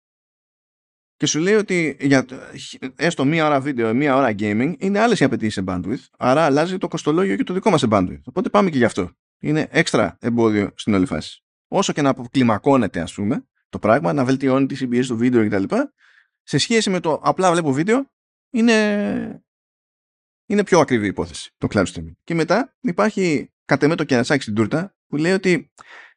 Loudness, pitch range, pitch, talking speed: -19 LUFS, 125-185 Hz, 145 Hz, 190 wpm